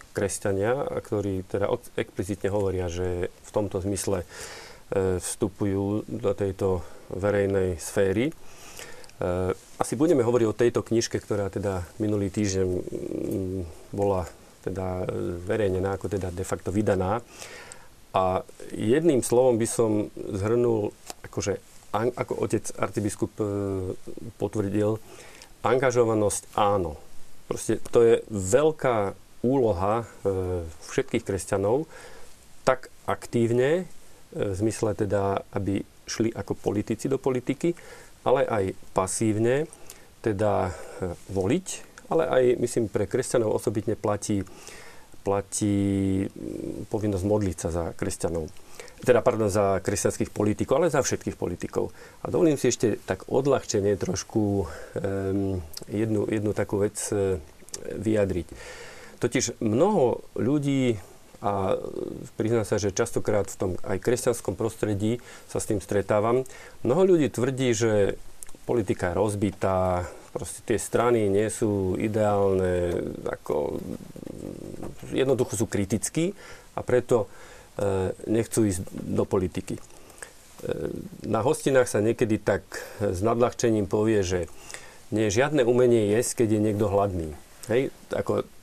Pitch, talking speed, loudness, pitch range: 105 Hz, 110 wpm, -26 LUFS, 95-115 Hz